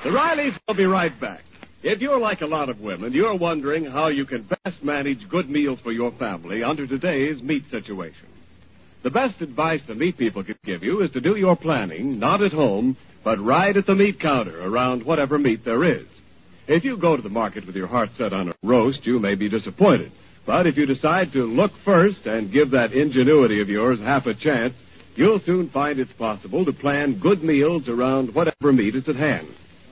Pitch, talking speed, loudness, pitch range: 145 Hz, 210 wpm, -21 LUFS, 120-175 Hz